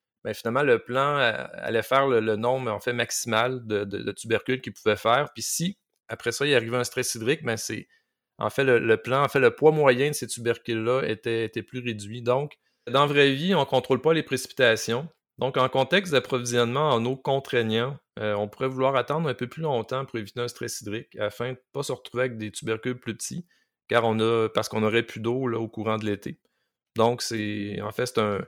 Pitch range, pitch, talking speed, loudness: 110-135 Hz, 120 Hz, 230 wpm, -25 LUFS